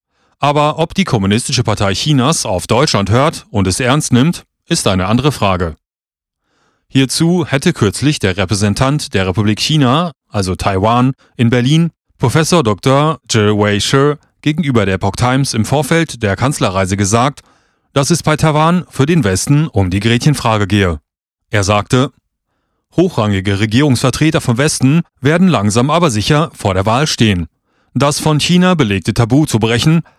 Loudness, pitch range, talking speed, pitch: -13 LUFS, 105-150 Hz, 145 wpm, 125 Hz